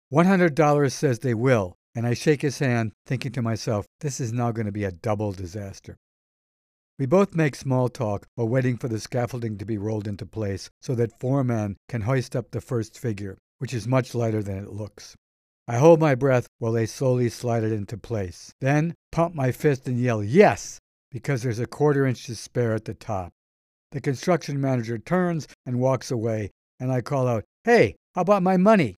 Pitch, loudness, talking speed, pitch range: 120 Hz, -24 LUFS, 200 wpm, 110-135 Hz